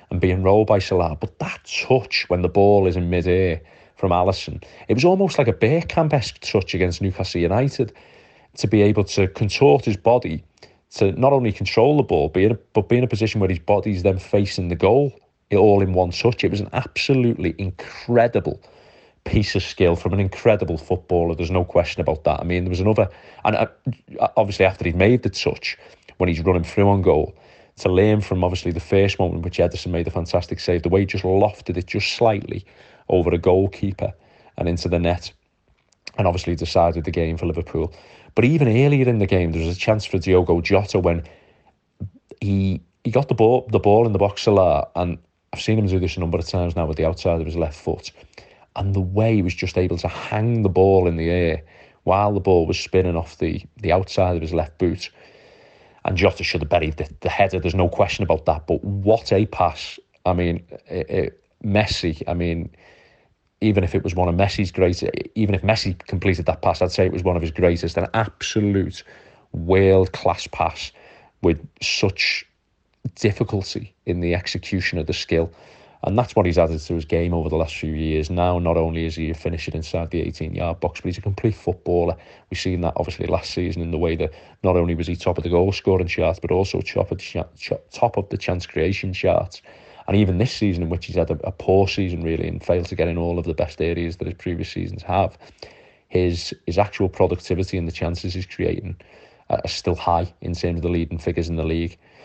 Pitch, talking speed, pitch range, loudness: 90 Hz, 215 wpm, 85-100 Hz, -21 LUFS